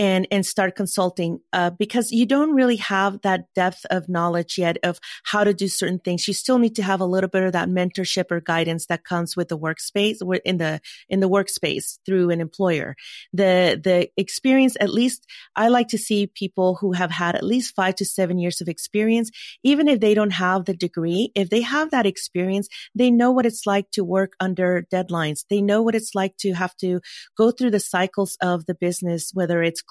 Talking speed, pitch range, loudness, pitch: 215 wpm, 180-210 Hz, -21 LUFS, 190 Hz